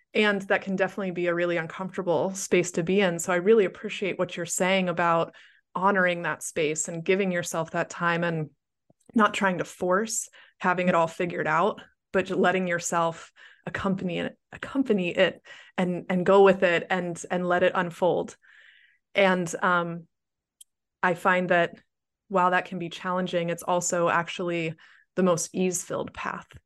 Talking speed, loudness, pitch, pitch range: 165 wpm, -26 LUFS, 180 Hz, 170-190 Hz